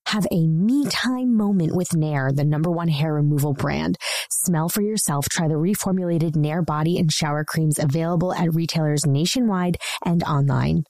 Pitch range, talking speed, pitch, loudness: 150-180 Hz, 165 wpm, 165 Hz, -21 LUFS